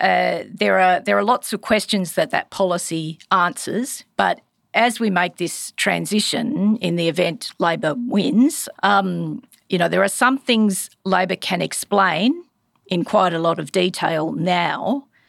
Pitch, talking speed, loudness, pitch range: 195 Hz, 155 wpm, -20 LUFS, 175-225 Hz